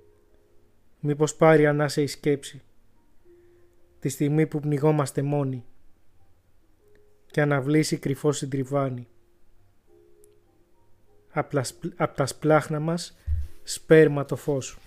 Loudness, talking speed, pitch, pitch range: -24 LUFS, 85 wpm, 135 Hz, 105-150 Hz